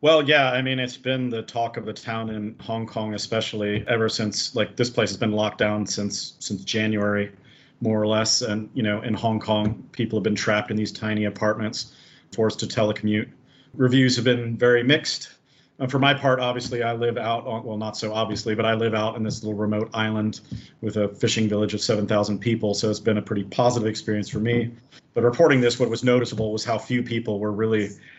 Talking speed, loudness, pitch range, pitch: 215 wpm, -23 LUFS, 105-120 Hz, 110 Hz